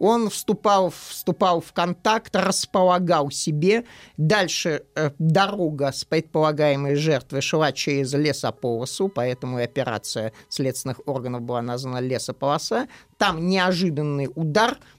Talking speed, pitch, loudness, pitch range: 110 wpm, 155 Hz, -23 LUFS, 135-180 Hz